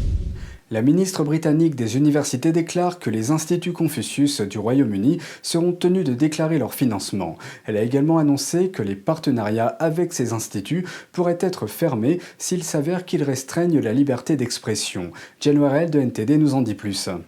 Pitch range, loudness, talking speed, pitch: 115-165 Hz, -21 LUFS, 155 wpm, 145 Hz